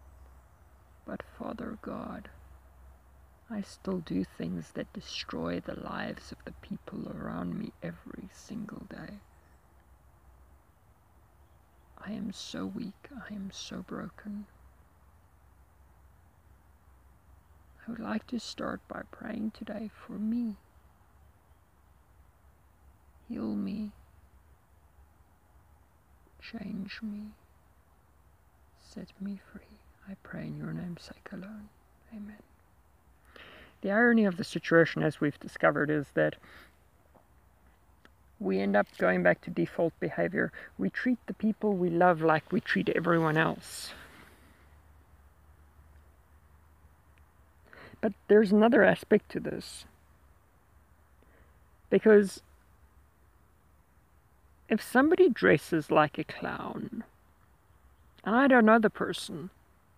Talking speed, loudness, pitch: 100 wpm, -30 LUFS, 85 Hz